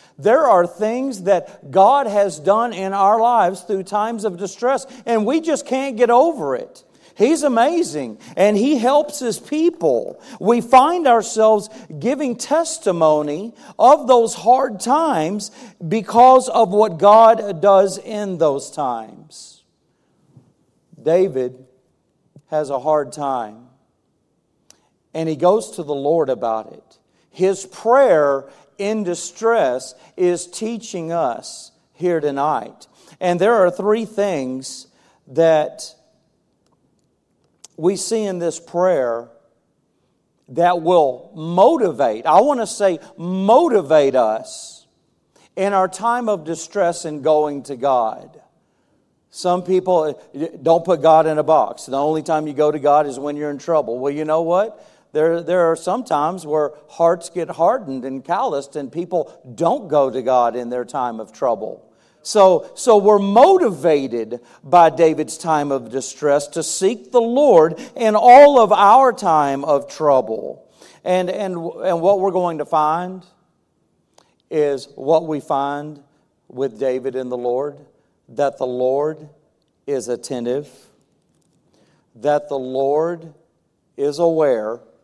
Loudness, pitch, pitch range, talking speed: -17 LUFS, 170 Hz, 145-210 Hz, 135 wpm